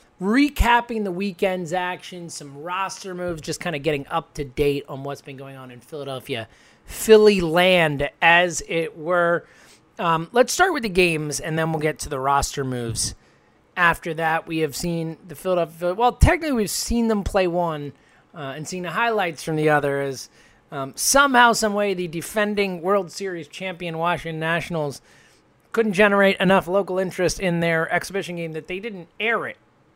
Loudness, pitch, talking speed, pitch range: -21 LUFS, 170 Hz, 175 wpm, 155-195 Hz